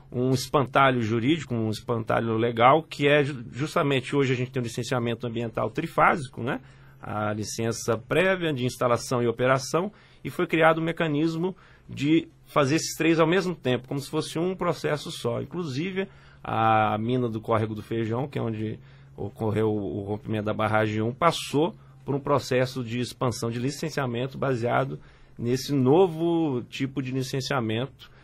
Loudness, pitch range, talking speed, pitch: -26 LUFS, 115-150 Hz, 155 wpm, 130 Hz